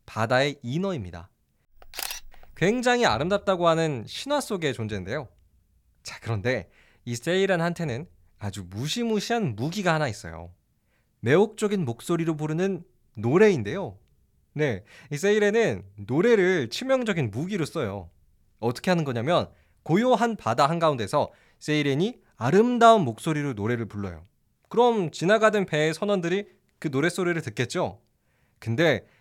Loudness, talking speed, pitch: -25 LUFS, 300 characters per minute, 150 Hz